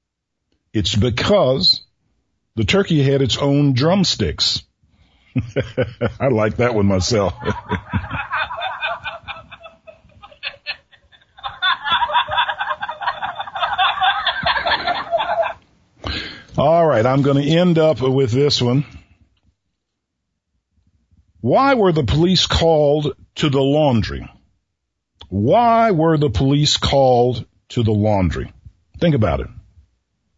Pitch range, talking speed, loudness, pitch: 95-150 Hz, 85 wpm, -17 LUFS, 120 Hz